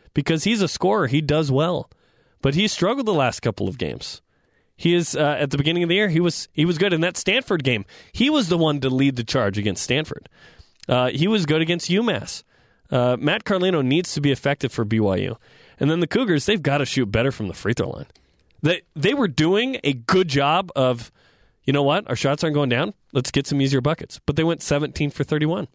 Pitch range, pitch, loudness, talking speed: 135-175 Hz, 150 Hz, -21 LUFS, 230 wpm